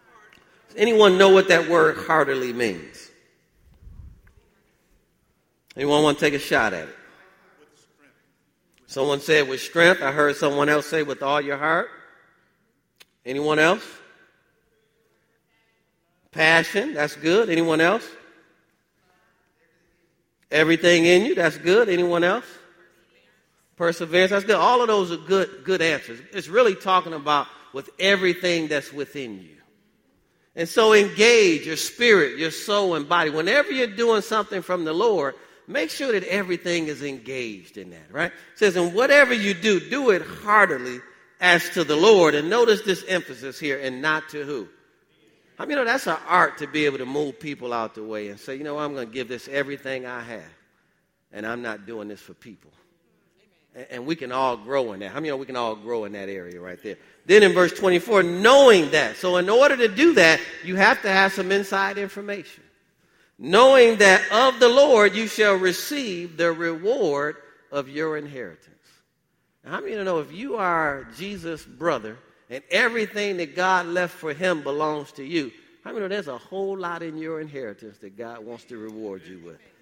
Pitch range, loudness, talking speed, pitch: 140-195 Hz, -20 LUFS, 180 wpm, 165 Hz